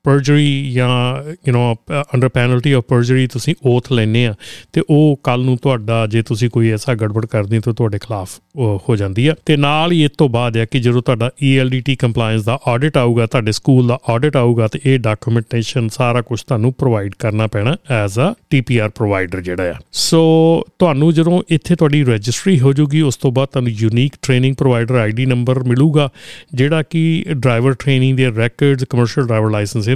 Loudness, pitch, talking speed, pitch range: -15 LUFS, 125 Hz, 170 wpm, 115-140 Hz